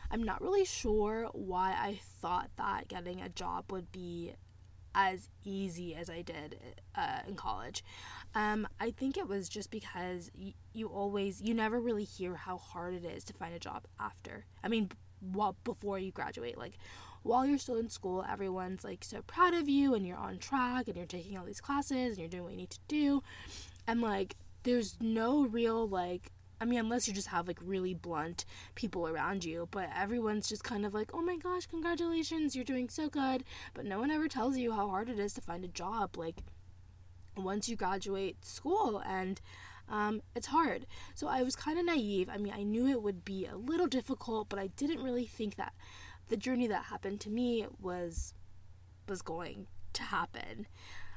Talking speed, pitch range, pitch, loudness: 195 wpm, 170-245 Hz, 200 Hz, -37 LUFS